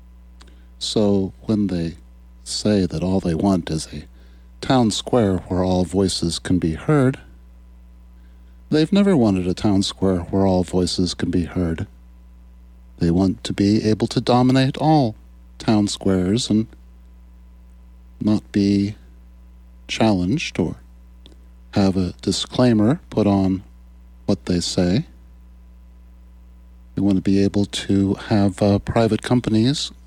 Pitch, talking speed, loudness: 90 Hz, 125 wpm, -20 LUFS